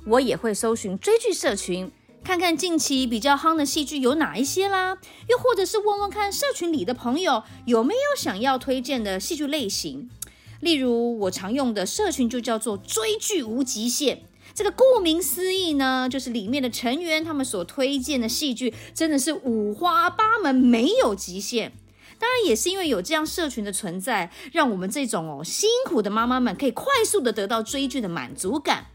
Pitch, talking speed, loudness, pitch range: 275 Hz, 285 characters per minute, -23 LUFS, 235-345 Hz